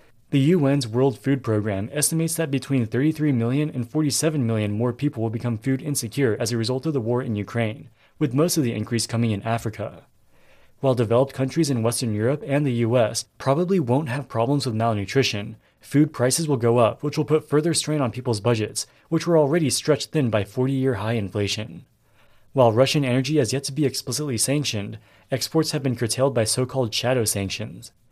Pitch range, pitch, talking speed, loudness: 115-145 Hz, 125 Hz, 195 wpm, -23 LUFS